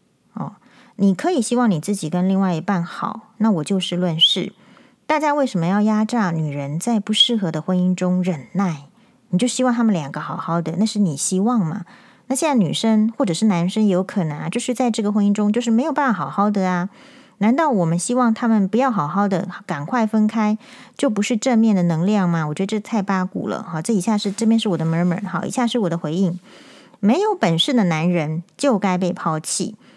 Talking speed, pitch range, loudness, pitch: 320 characters per minute, 180-235 Hz, -19 LUFS, 205 Hz